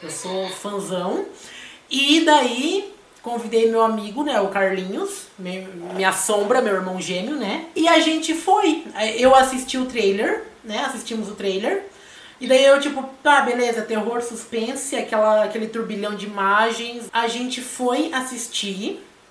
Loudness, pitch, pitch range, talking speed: -20 LUFS, 235 Hz, 205-275 Hz, 150 wpm